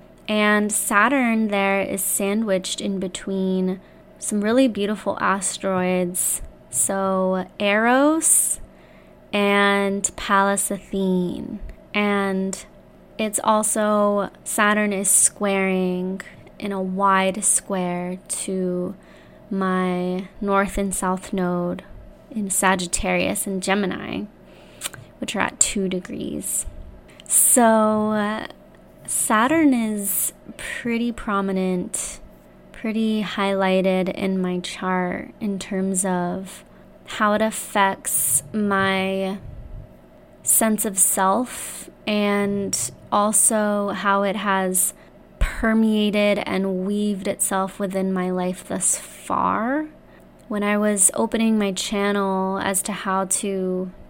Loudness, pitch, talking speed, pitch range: -21 LUFS, 195 Hz, 95 wpm, 190-210 Hz